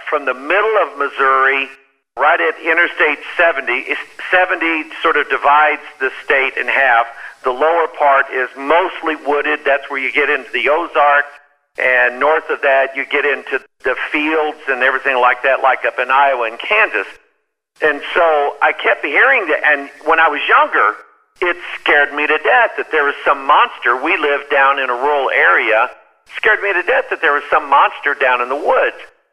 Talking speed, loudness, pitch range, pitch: 185 wpm, -14 LUFS, 135-155 Hz, 145 Hz